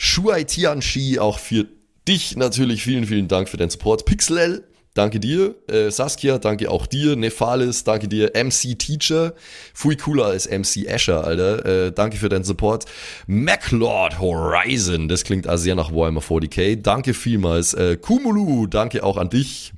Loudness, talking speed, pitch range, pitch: -19 LUFS, 155 wpm, 95-130 Hz, 110 Hz